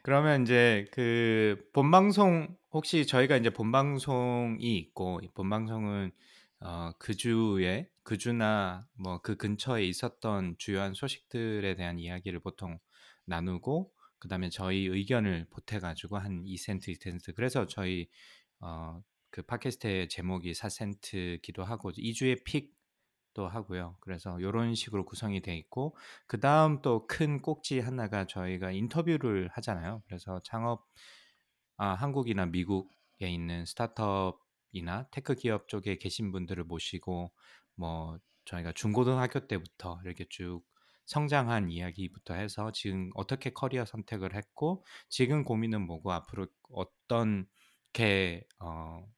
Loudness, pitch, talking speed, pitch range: -33 LUFS, 100 Hz, 280 characters per minute, 90-120 Hz